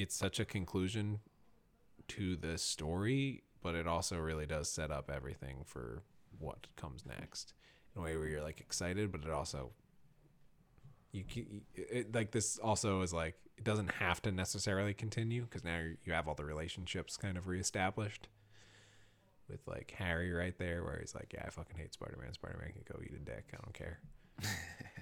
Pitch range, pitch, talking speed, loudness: 85-110 Hz, 95 Hz, 180 wpm, -41 LUFS